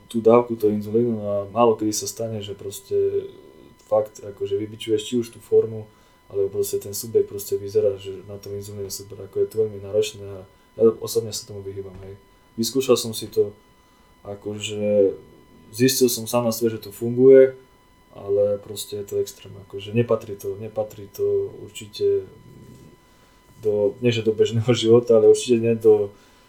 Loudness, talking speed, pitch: -22 LUFS, 170 wpm, 115 Hz